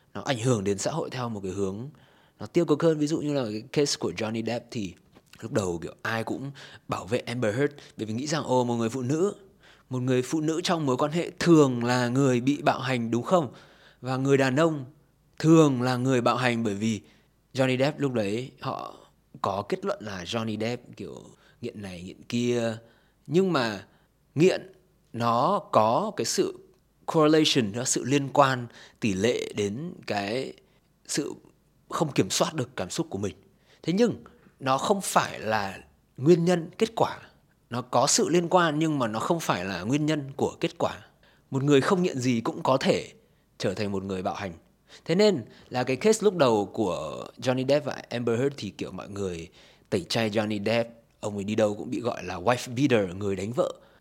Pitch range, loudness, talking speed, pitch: 115-150 Hz, -26 LUFS, 205 wpm, 130 Hz